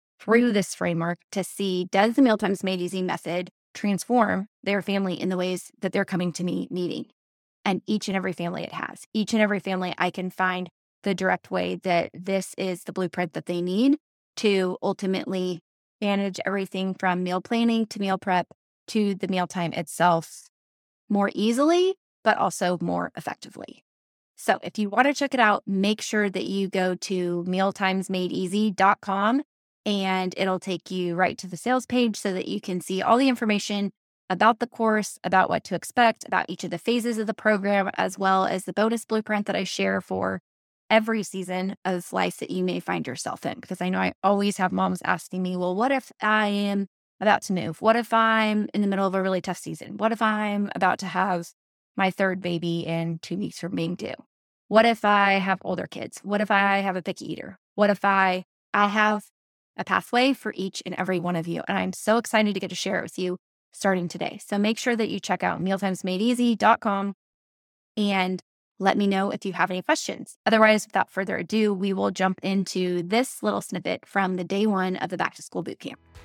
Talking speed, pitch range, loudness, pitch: 200 wpm, 180-210 Hz, -25 LUFS, 195 Hz